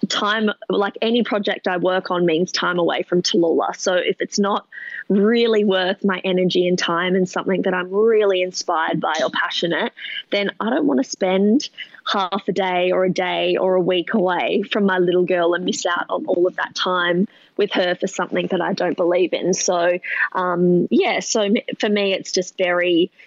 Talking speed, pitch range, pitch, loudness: 200 wpm, 180-210 Hz, 185 Hz, -19 LUFS